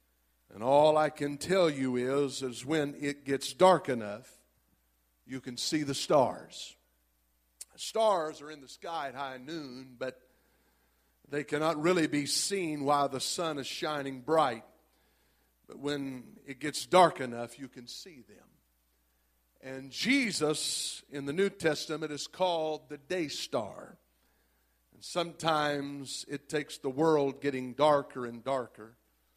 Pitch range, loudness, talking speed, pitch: 120-155 Hz, -31 LUFS, 140 wpm, 140 Hz